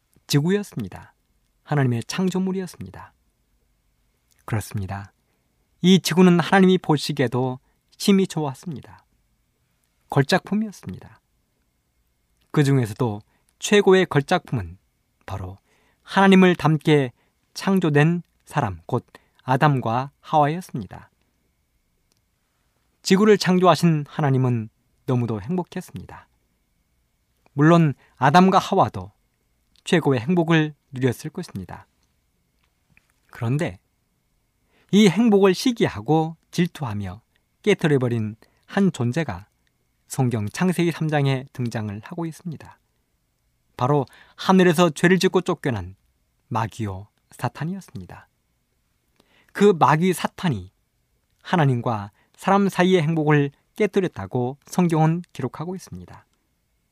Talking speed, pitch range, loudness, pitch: 235 characters per minute, 105-180 Hz, -21 LUFS, 145 Hz